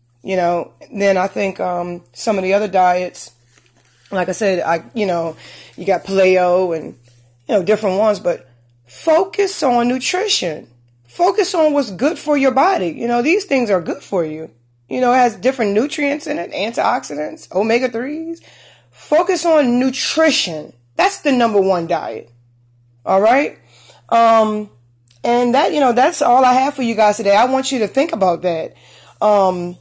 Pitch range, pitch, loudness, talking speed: 170-265 Hz, 210 Hz, -15 LUFS, 170 wpm